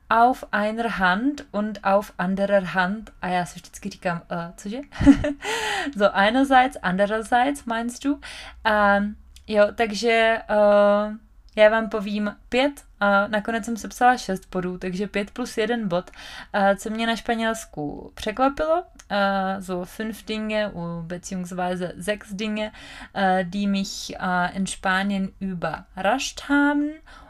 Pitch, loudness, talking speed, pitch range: 210 Hz, -23 LUFS, 130 wpm, 190-230 Hz